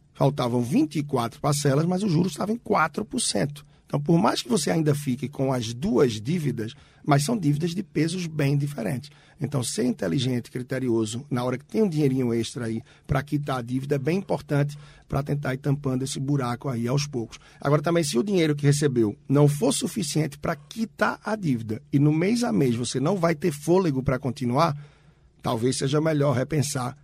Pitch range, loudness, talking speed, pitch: 130-160 Hz, -25 LUFS, 190 wpm, 145 Hz